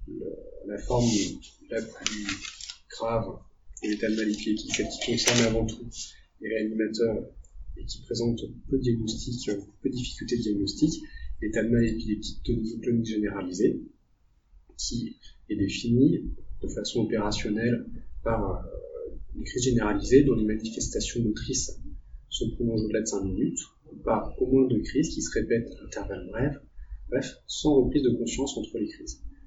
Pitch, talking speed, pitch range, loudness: 110 Hz, 155 wpm, 105-120 Hz, -28 LUFS